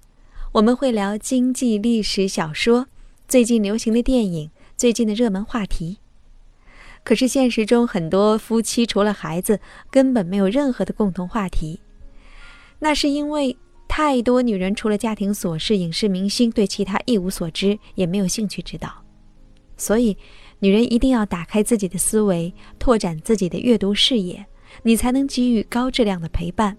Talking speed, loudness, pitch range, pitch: 255 characters per minute, -20 LUFS, 195-240 Hz, 215 Hz